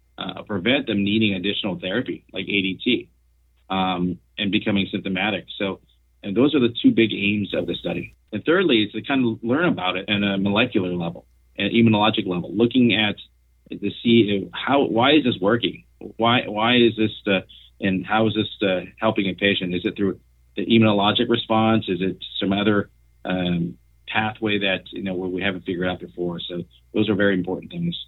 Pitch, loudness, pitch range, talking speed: 100 Hz, -21 LUFS, 90-110 Hz, 185 wpm